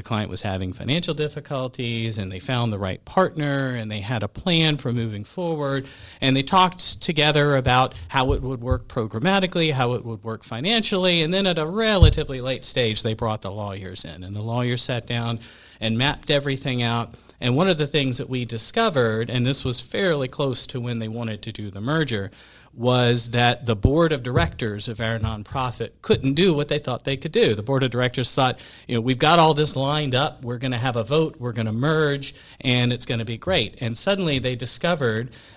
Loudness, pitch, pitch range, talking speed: -22 LUFS, 125 Hz, 115-145 Hz, 215 wpm